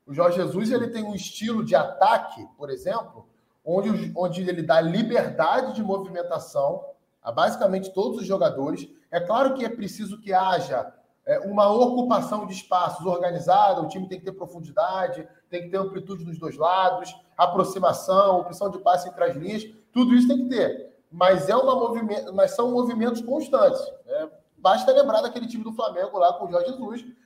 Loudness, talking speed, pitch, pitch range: -23 LUFS, 180 wpm, 200 Hz, 180-245 Hz